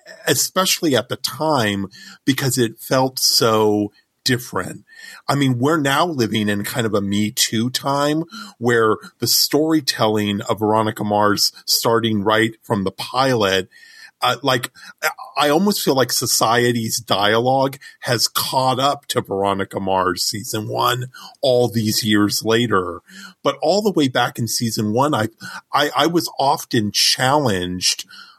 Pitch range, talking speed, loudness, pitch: 105-140 Hz, 140 wpm, -18 LUFS, 120 Hz